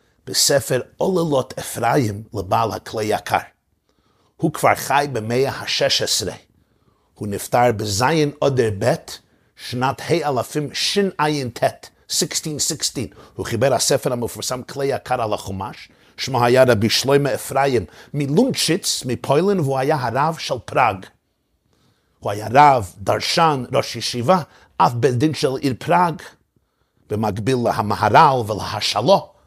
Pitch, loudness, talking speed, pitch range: 130 Hz, -19 LUFS, 115 wpm, 115-145 Hz